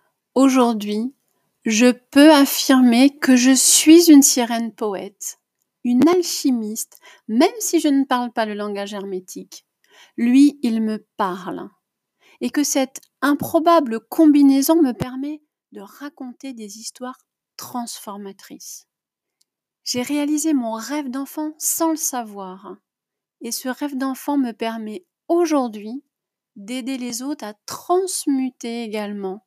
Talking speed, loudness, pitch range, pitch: 120 wpm, -18 LUFS, 225-290 Hz, 260 Hz